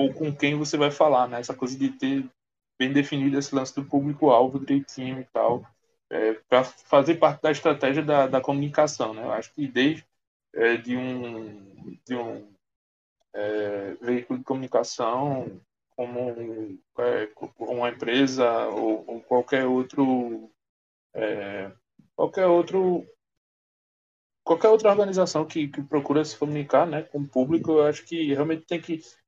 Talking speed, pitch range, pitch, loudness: 150 wpm, 120-155 Hz, 140 Hz, -25 LUFS